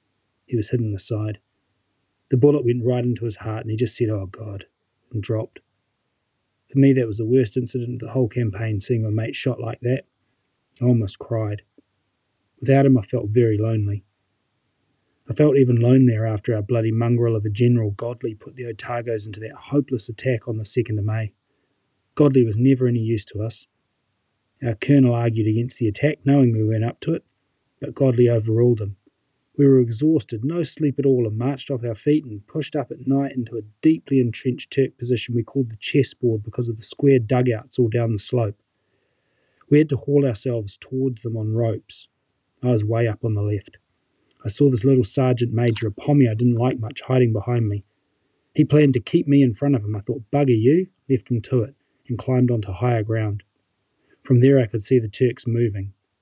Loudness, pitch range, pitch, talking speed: -21 LUFS, 110-130 Hz, 120 Hz, 205 wpm